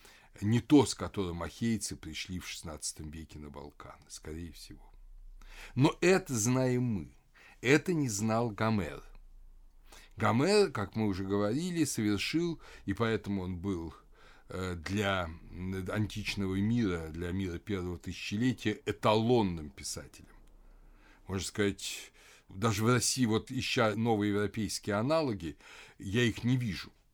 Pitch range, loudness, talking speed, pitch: 90-115 Hz, -32 LUFS, 120 wpm, 105 Hz